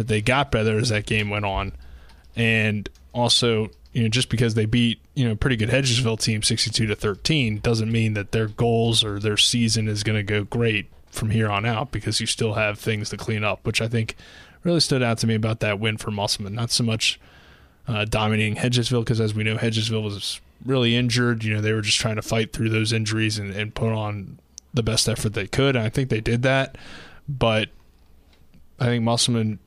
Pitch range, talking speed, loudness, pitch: 105-120 Hz, 220 wpm, -22 LUFS, 110 Hz